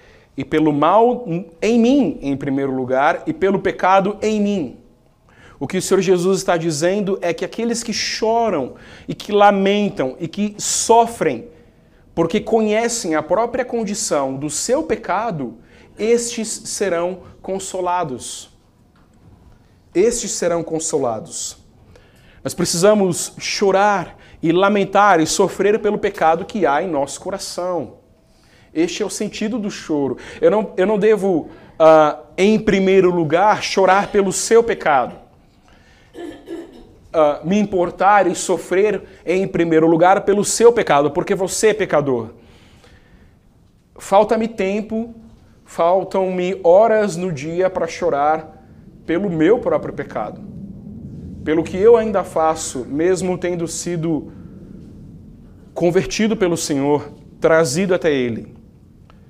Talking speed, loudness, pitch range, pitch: 120 wpm, -17 LUFS, 165-210 Hz, 185 Hz